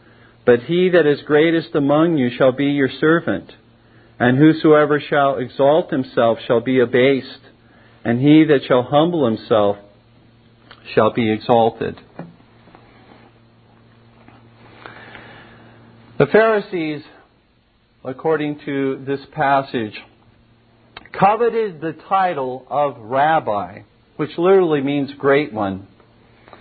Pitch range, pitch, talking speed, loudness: 115-150 Hz, 125 Hz, 100 wpm, -17 LUFS